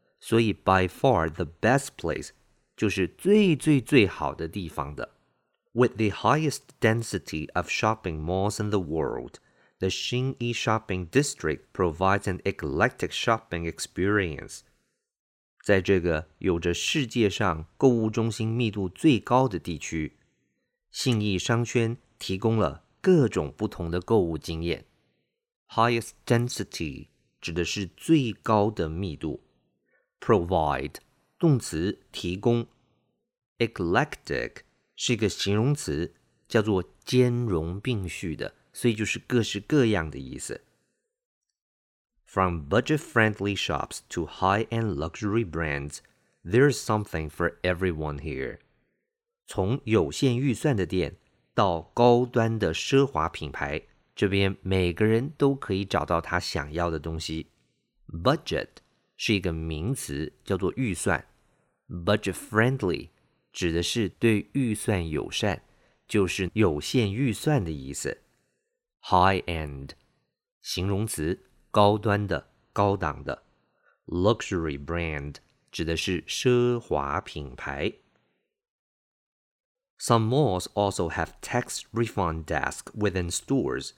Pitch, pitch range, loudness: 100 Hz, 85-120 Hz, -27 LUFS